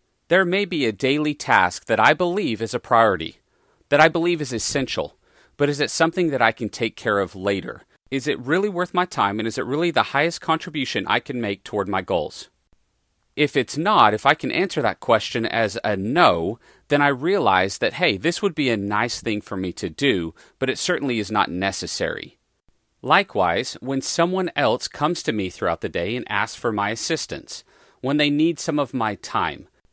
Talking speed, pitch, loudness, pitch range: 205 wpm, 140 Hz, -21 LUFS, 110-165 Hz